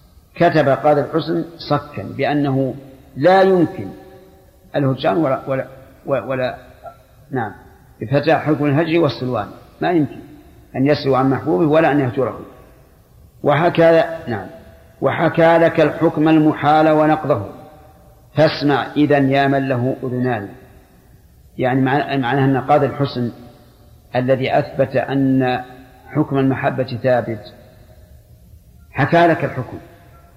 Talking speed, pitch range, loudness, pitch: 100 wpm, 130-155 Hz, -17 LUFS, 140 Hz